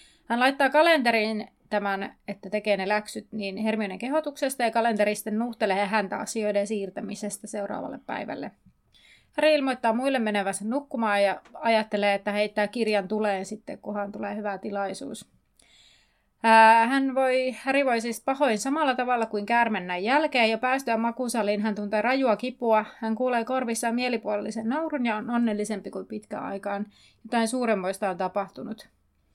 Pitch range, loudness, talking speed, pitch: 205-245 Hz, -26 LUFS, 140 wpm, 220 Hz